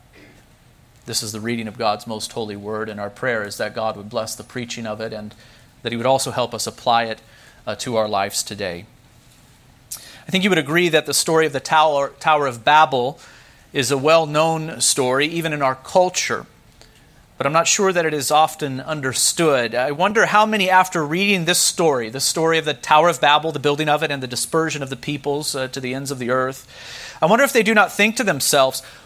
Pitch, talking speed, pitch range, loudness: 140 Hz, 220 wpm, 120-160 Hz, -19 LUFS